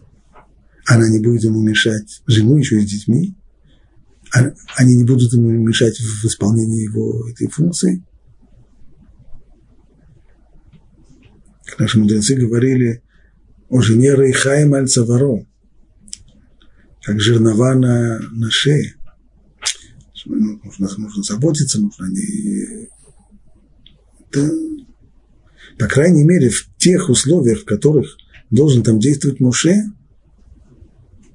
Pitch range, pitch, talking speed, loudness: 110-140 Hz, 120 Hz, 95 wpm, -15 LUFS